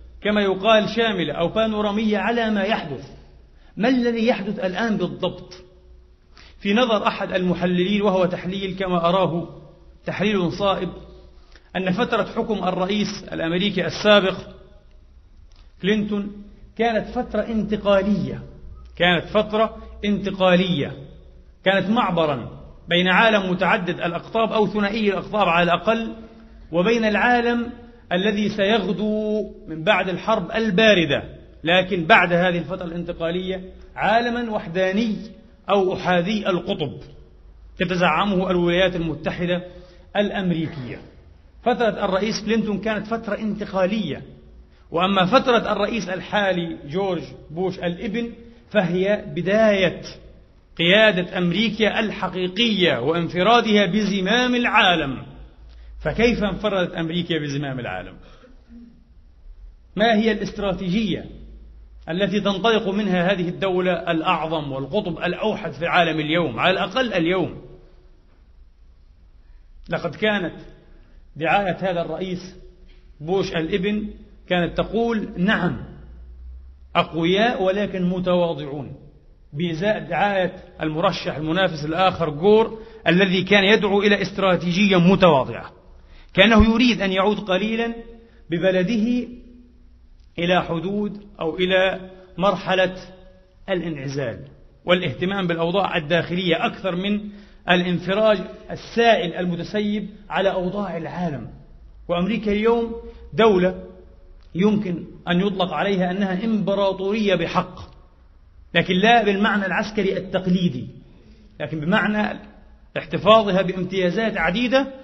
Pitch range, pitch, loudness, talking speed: 170-210 Hz, 185 Hz, -21 LUFS, 95 wpm